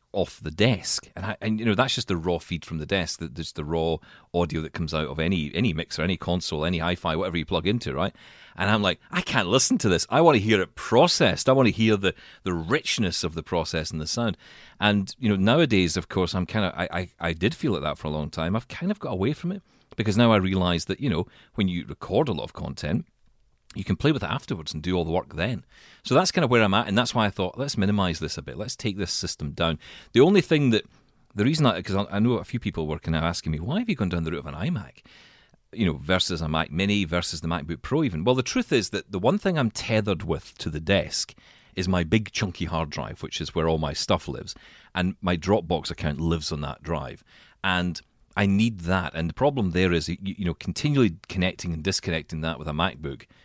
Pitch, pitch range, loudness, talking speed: 90 Hz, 80-110 Hz, -25 LUFS, 260 wpm